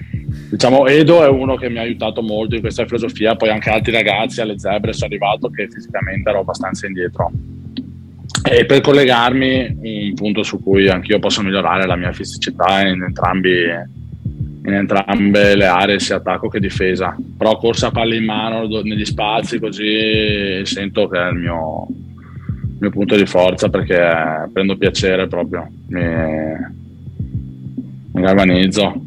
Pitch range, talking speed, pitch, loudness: 95-115 Hz, 155 wpm, 105 Hz, -15 LUFS